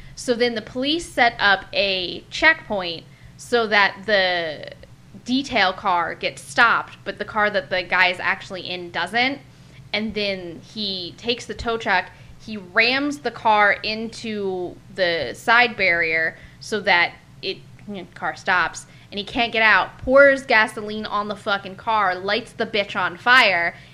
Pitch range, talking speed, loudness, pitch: 185-230 Hz, 155 wpm, -20 LUFS, 205 Hz